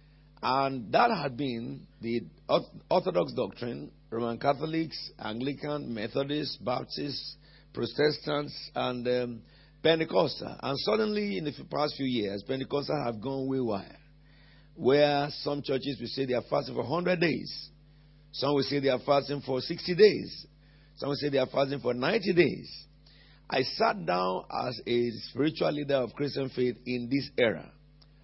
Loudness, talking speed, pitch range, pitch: -30 LUFS, 150 wpm, 130-150 Hz, 140 Hz